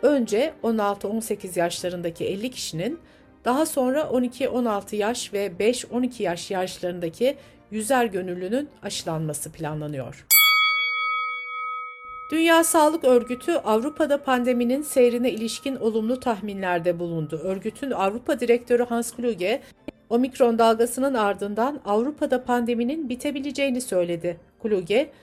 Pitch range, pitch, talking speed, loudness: 200-275 Hz, 240 Hz, 95 wpm, -23 LUFS